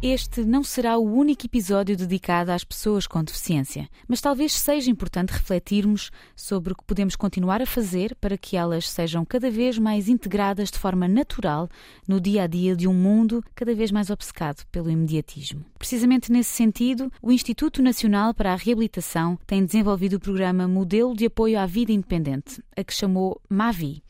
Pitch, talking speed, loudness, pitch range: 205 Hz, 175 wpm, -23 LUFS, 185-235 Hz